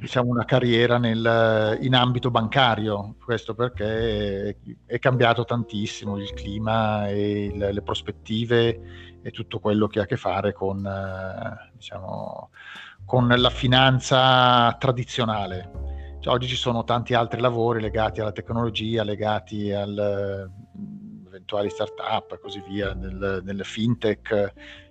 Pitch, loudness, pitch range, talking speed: 110 Hz, -23 LUFS, 100-120 Hz, 130 wpm